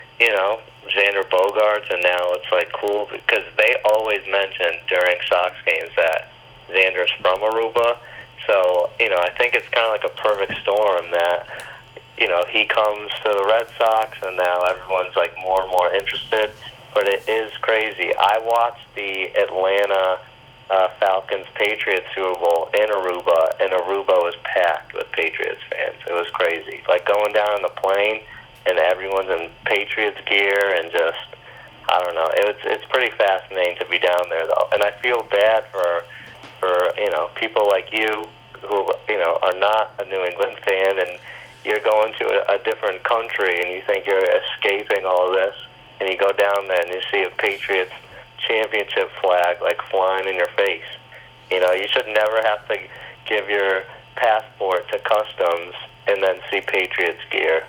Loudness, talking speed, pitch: -20 LUFS, 175 wpm, 110 Hz